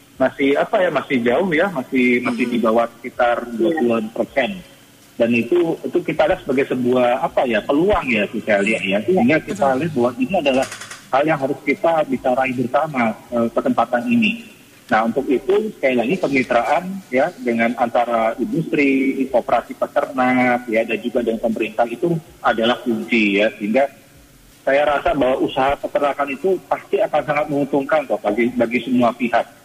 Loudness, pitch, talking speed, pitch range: -18 LUFS, 130 Hz, 160 wpm, 120-145 Hz